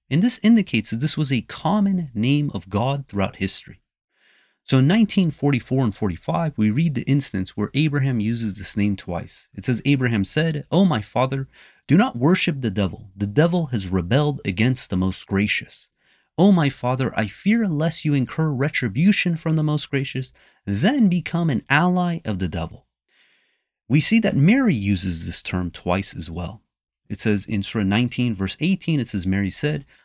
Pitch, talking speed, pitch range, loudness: 130 Hz, 180 wpm, 100-160 Hz, -21 LUFS